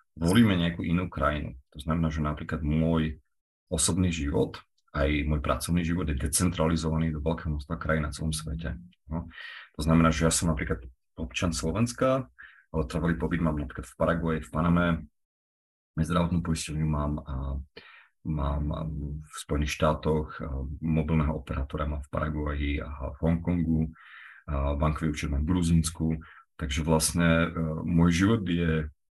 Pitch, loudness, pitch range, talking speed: 80 Hz, -28 LUFS, 75-85 Hz, 140 wpm